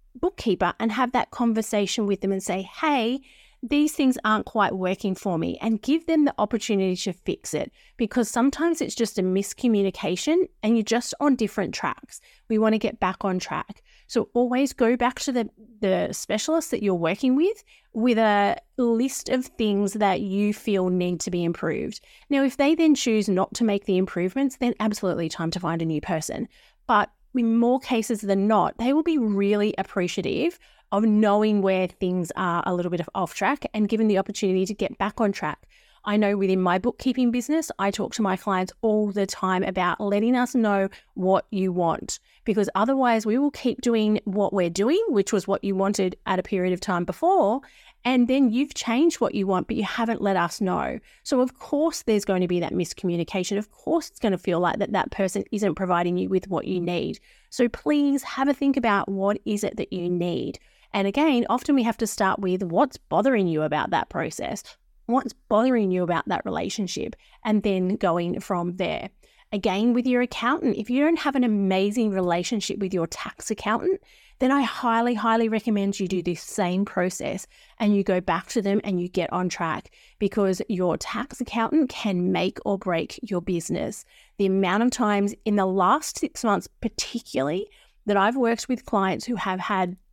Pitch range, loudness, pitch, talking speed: 190-245 Hz, -24 LUFS, 210 Hz, 200 wpm